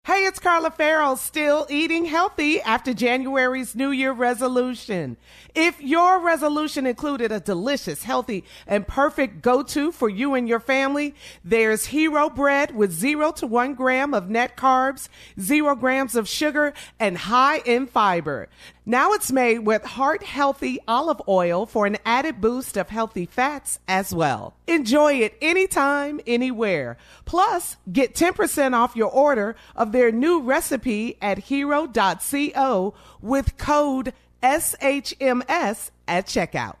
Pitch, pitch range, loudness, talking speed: 265 Hz, 230-295 Hz, -21 LUFS, 140 wpm